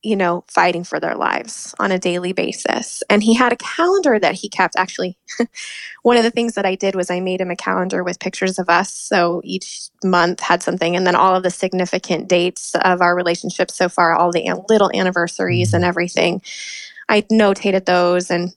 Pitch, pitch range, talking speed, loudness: 185 Hz, 175-205 Hz, 205 wpm, -17 LUFS